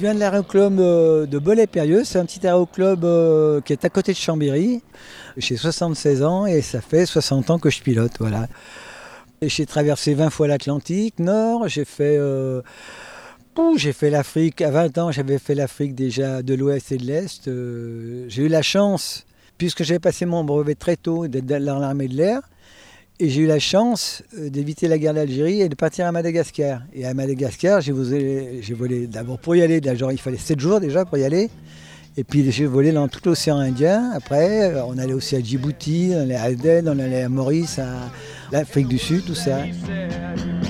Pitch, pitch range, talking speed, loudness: 150 Hz, 135-170 Hz, 195 wpm, -20 LUFS